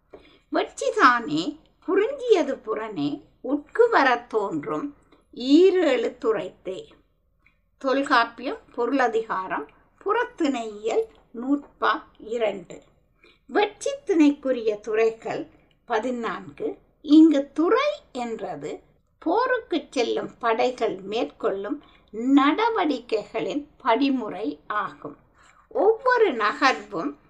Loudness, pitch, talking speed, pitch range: -24 LUFS, 275 Hz, 60 wpm, 230-350 Hz